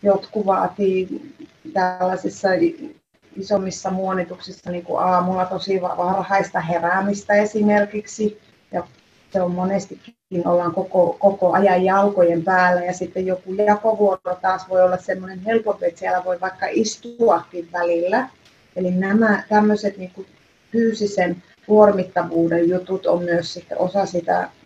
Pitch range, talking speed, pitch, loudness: 180-205 Hz, 120 wpm, 185 Hz, -20 LUFS